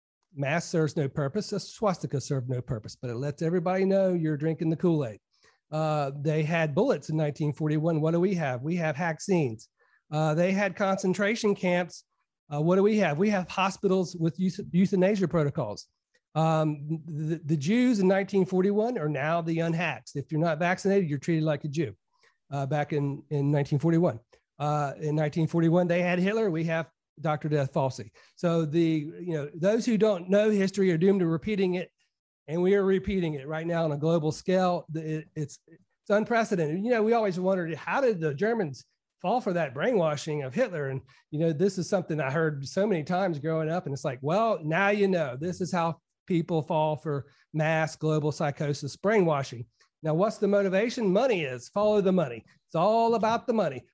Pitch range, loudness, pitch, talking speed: 155-190 Hz, -27 LUFS, 165 Hz, 190 wpm